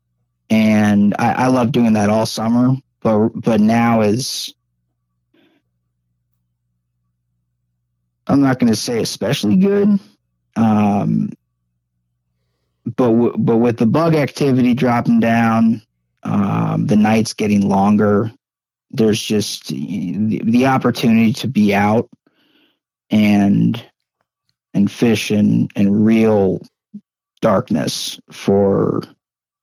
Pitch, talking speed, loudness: 105 Hz, 105 wpm, -16 LUFS